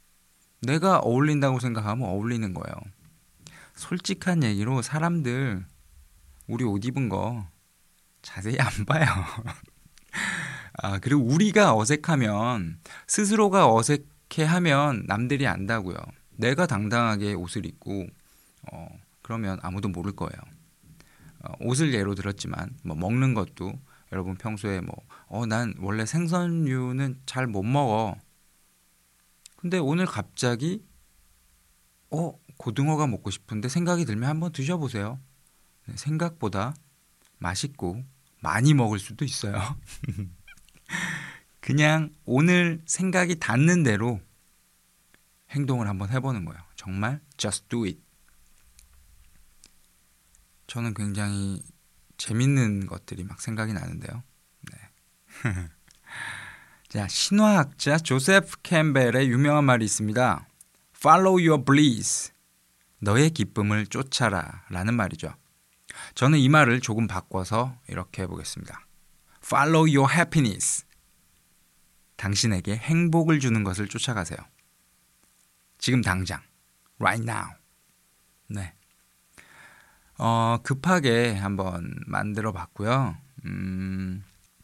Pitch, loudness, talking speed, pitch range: 115 Hz, -25 LUFS, 245 characters per minute, 95-140 Hz